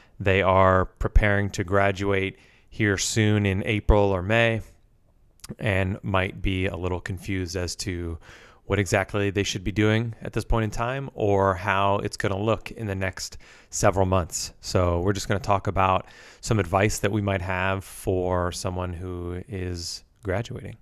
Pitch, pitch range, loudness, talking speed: 100 Hz, 95-105 Hz, -25 LUFS, 170 wpm